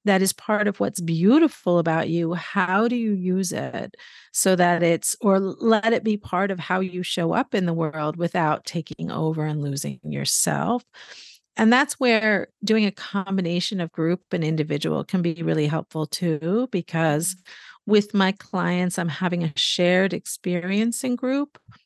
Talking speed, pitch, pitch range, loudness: 165 wpm, 185 Hz, 165-210 Hz, -23 LUFS